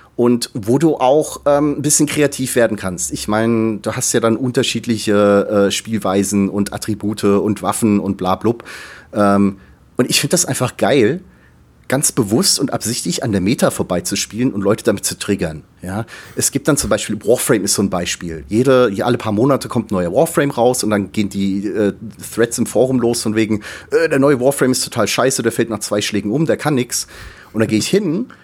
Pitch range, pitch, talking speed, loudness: 100-130 Hz, 110 Hz, 205 wpm, -16 LUFS